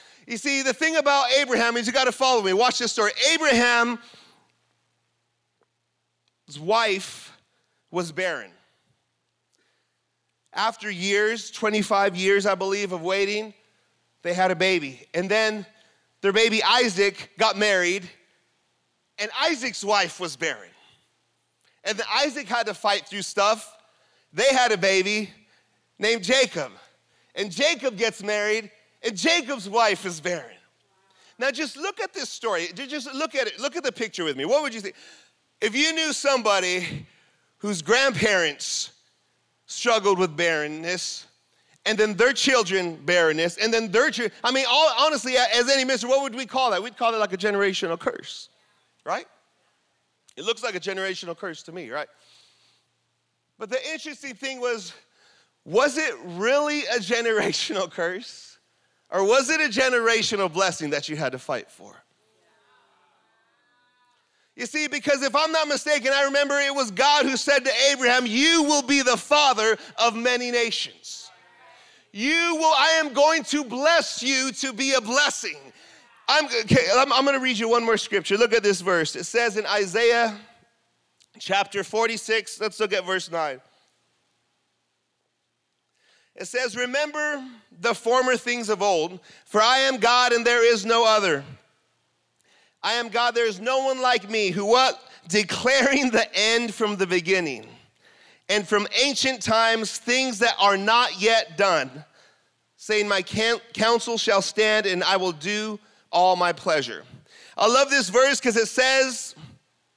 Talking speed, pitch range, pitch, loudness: 150 wpm, 200-265 Hz, 230 Hz, -22 LUFS